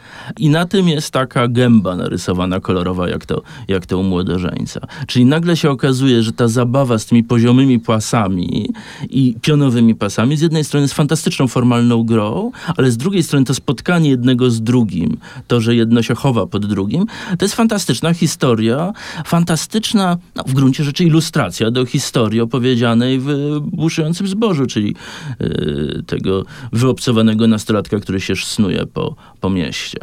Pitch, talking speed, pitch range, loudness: 130 Hz, 155 wpm, 115-160 Hz, -15 LUFS